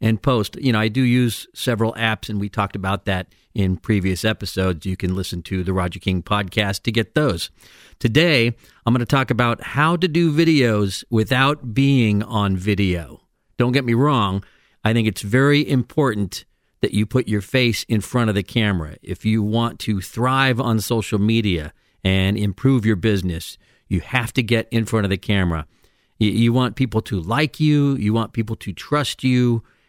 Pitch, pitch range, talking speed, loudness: 110 Hz, 100-125 Hz, 190 wpm, -20 LUFS